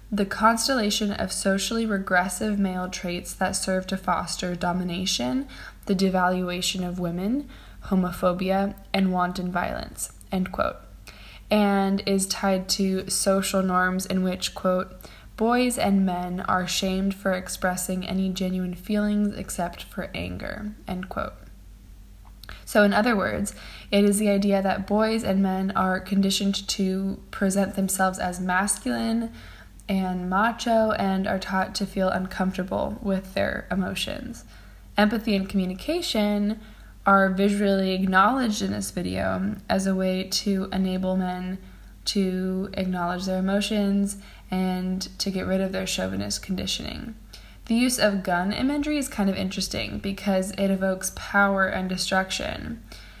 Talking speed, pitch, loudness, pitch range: 135 wpm, 190 Hz, -25 LUFS, 185-200 Hz